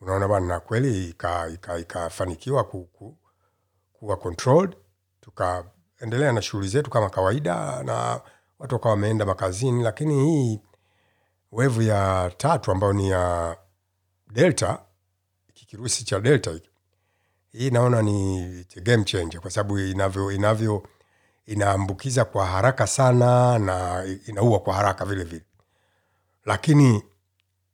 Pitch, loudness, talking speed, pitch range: 100 Hz, -23 LUFS, 105 wpm, 95-115 Hz